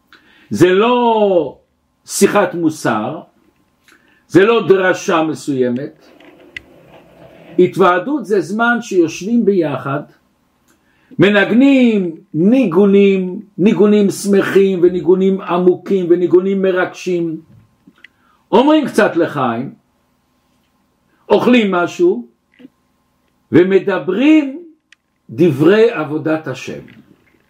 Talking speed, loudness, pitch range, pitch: 65 wpm, -13 LUFS, 175-210 Hz, 185 Hz